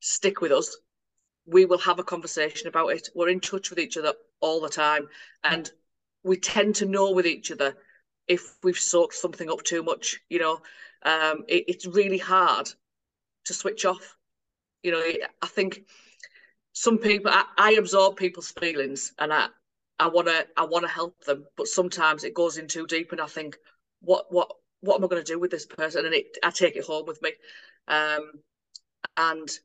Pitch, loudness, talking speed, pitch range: 175 Hz, -25 LUFS, 190 wpm, 160-190 Hz